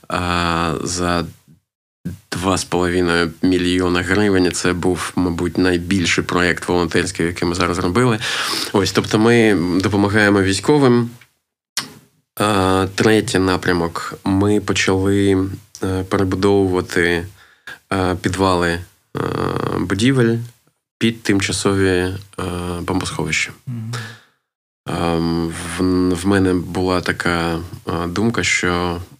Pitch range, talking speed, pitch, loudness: 90-100 Hz, 75 wpm, 95 Hz, -18 LUFS